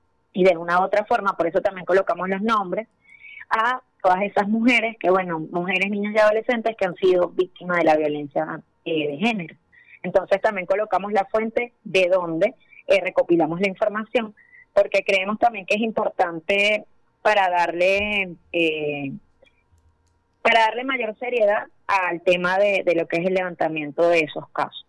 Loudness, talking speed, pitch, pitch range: -21 LUFS, 165 wpm, 195 Hz, 175-215 Hz